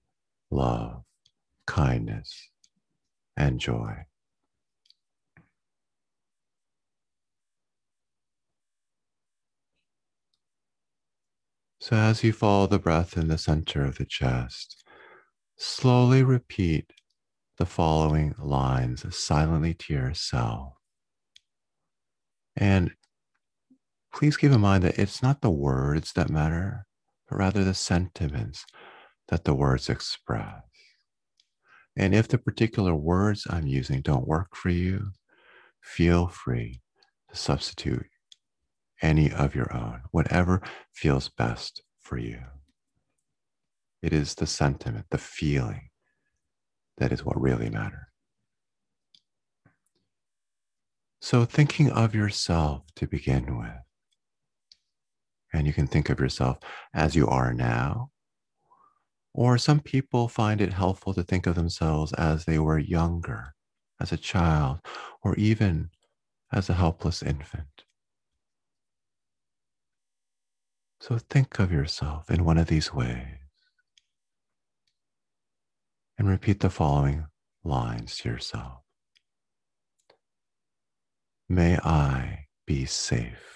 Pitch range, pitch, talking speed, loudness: 70-100 Hz, 85 Hz, 100 wpm, -26 LUFS